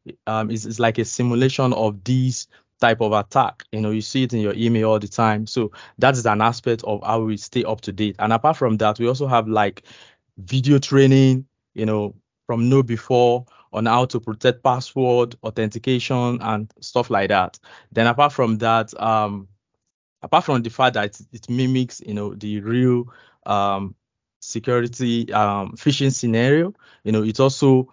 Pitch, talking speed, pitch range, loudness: 115 Hz, 180 wpm, 110-125 Hz, -20 LUFS